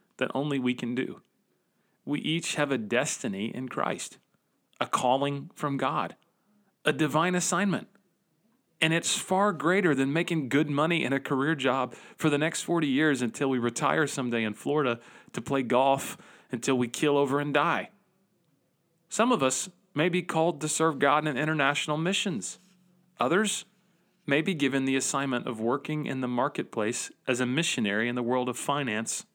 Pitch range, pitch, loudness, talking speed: 135-175 Hz, 150 Hz, -28 LUFS, 170 wpm